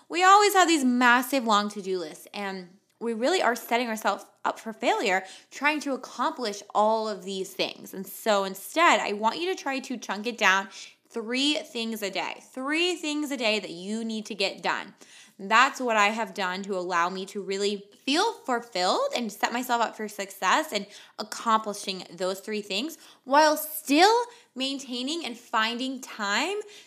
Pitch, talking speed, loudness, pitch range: 225 Hz, 180 wpm, -26 LUFS, 200-275 Hz